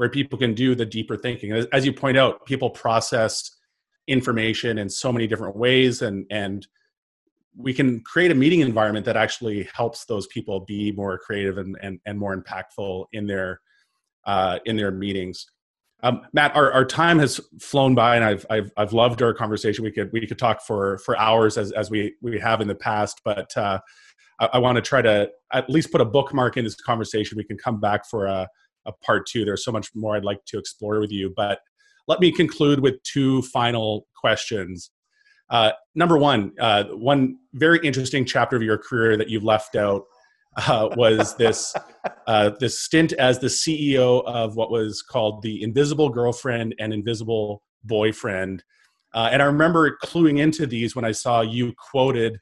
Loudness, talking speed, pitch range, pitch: -22 LUFS, 190 wpm, 105-135 Hz, 115 Hz